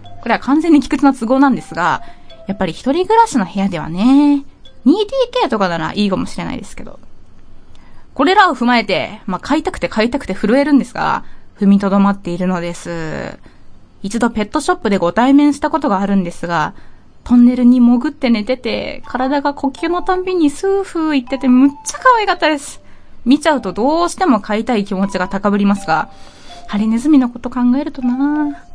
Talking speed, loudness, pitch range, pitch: 395 characters per minute, -15 LUFS, 200-295 Hz, 250 Hz